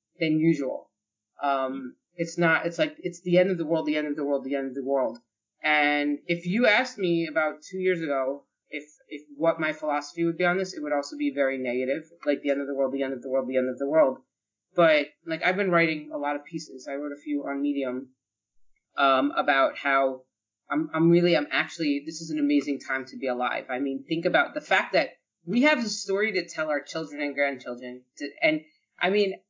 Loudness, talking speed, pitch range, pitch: -26 LUFS, 235 wpm, 135-170 Hz, 150 Hz